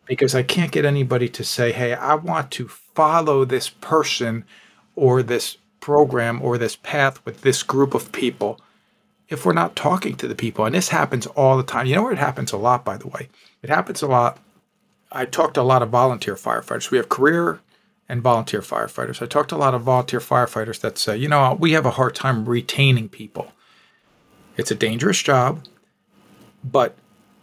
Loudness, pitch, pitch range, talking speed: -20 LUFS, 130 Hz, 120-140 Hz, 195 wpm